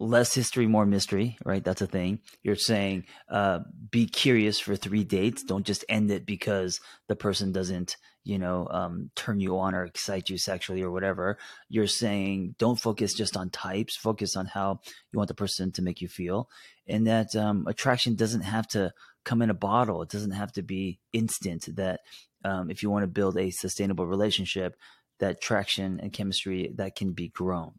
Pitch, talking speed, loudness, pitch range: 100 Hz, 190 wpm, -29 LUFS, 95-110 Hz